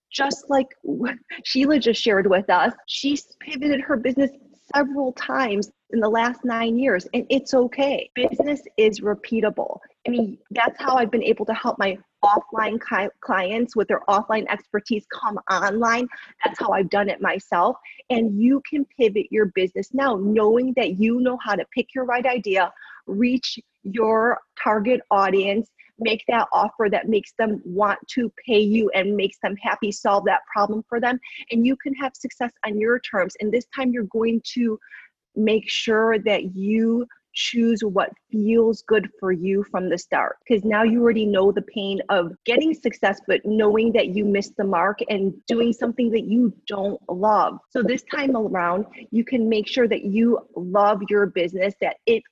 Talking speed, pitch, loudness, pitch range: 175 wpm, 225 Hz, -22 LUFS, 205-250 Hz